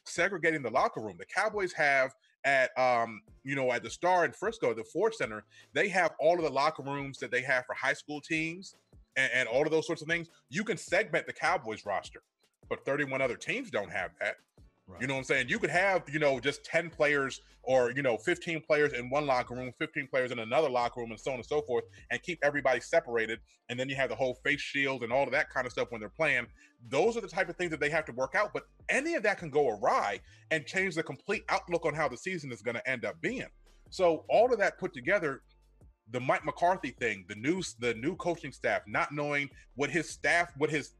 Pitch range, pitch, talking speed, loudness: 130-170 Hz, 145 Hz, 245 wpm, -31 LUFS